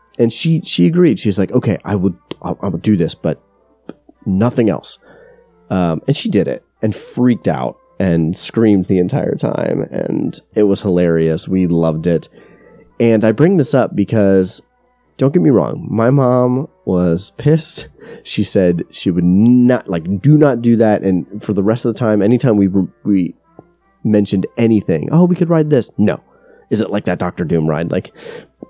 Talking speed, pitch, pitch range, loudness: 180 wpm, 105 Hz, 90-125 Hz, -15 LUFS